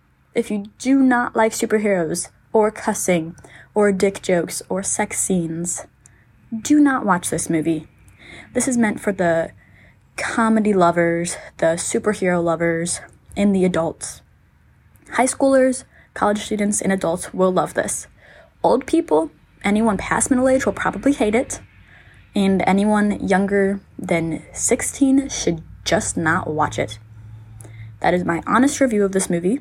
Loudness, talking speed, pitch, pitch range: -19 LUFS, 140 wpm, 195 Hz, 165-220 Hz